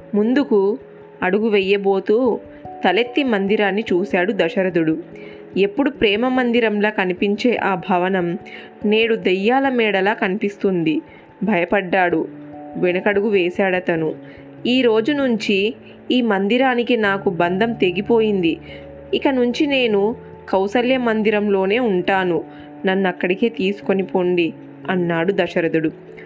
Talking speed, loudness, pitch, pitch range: 90 wpm, -18 LUFS, 200 Hz, 180-230 Hz